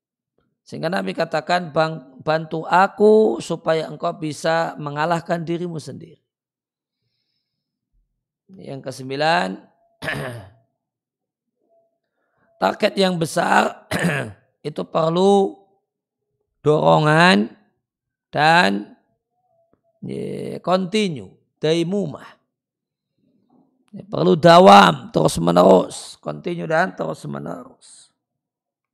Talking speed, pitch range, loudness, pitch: 65 wpm, 155-195 Hz, -18 LUFS, 170 Hz